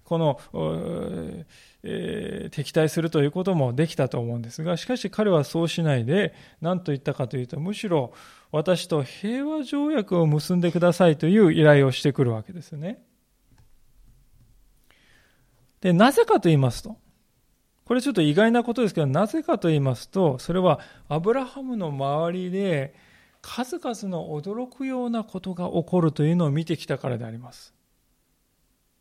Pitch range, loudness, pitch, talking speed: 150-210 Hz, -24 LUFS, 170 Hz, 325 characters per minute